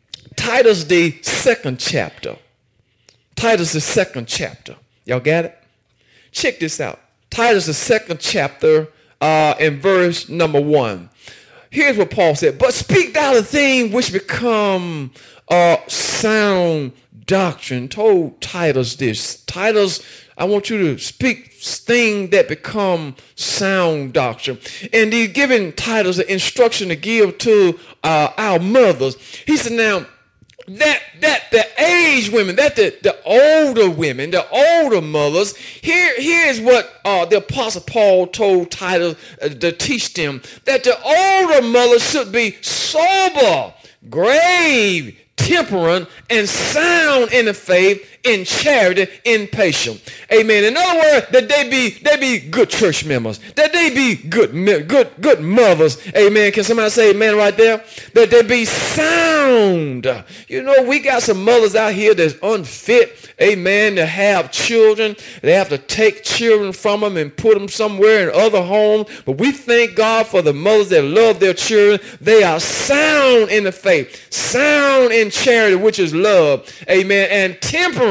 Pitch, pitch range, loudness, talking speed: 210 Hz, 170-245 Hz, -14 LUFS, 150 wpm